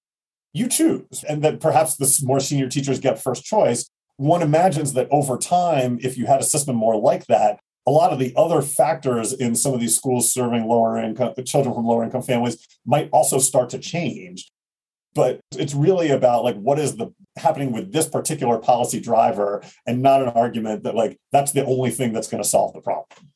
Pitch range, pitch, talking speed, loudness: 120-150 Hz, 130 Hz, 205 wpm, -20 LUFS